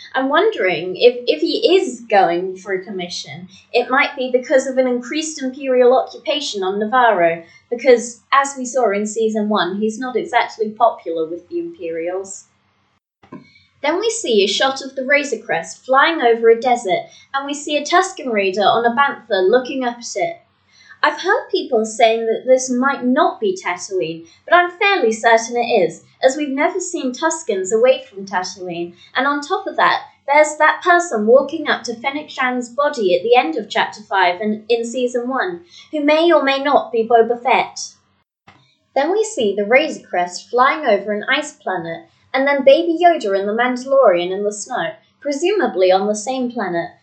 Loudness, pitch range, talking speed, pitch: -17 LUFS, 210-300 Hz, 180 wpm, 255 Hz